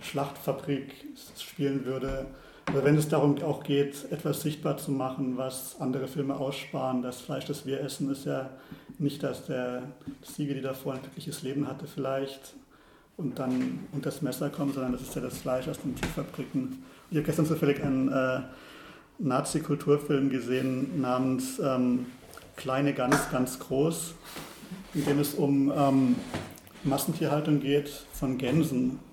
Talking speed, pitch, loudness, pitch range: 150 wpm, 140 Hz, -30 LUFS, 130-145 Hz